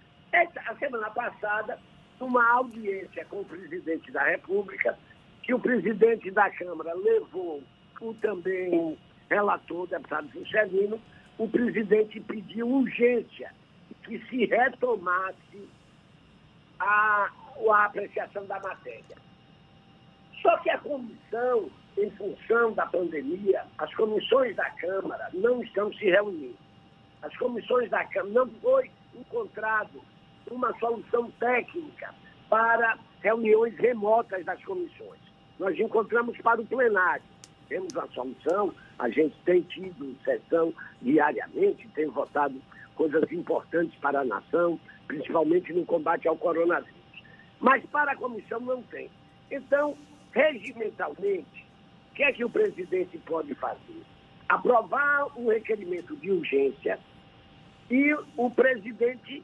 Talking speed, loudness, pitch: 120 wpm, -27 LUFS, 235 Hz